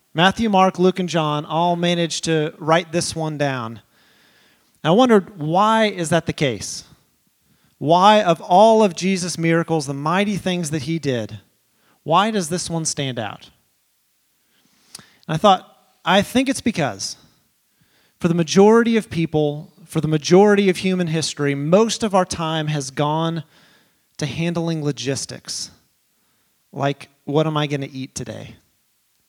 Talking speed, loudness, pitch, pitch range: 150 wpm, -19 LUFS, 165 Hz, 150-190 Hz